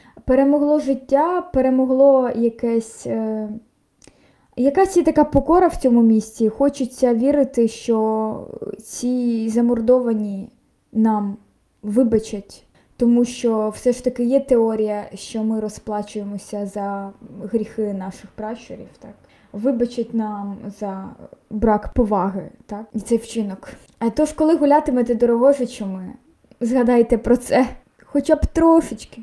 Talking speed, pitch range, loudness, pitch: 115 wpm, 215-260 Hz, -19 LUFS, 235 Hz